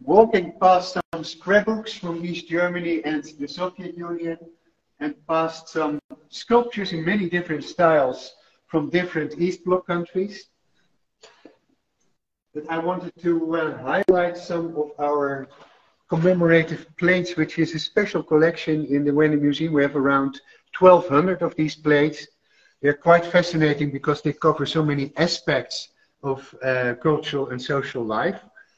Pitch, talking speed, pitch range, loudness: 165 Hz, 140 wpm, 150-175 Hz, -22 LUFS